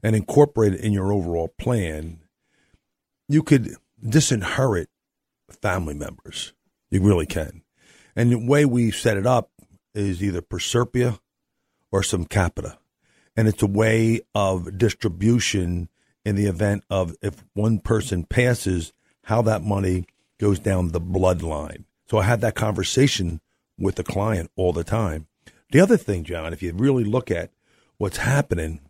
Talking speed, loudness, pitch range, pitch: 145 wpm, -22 LUFS, 90-115 Hz, 100 Hz